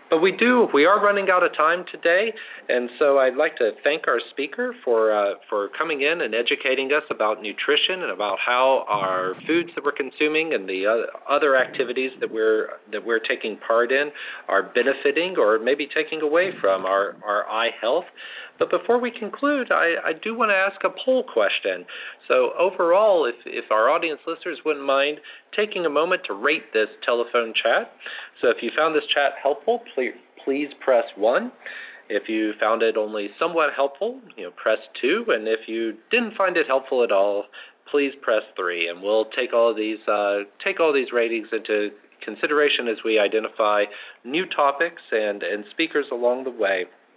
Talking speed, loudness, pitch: 185 wpm, -22 LUFS, 145 Hz